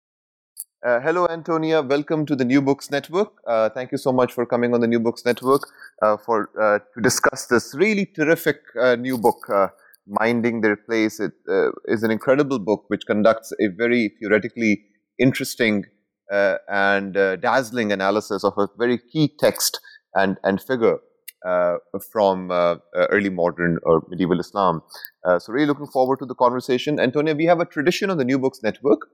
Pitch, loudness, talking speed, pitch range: 120 Hz, -21 LUFS, 180 wpm, 105-145 Hz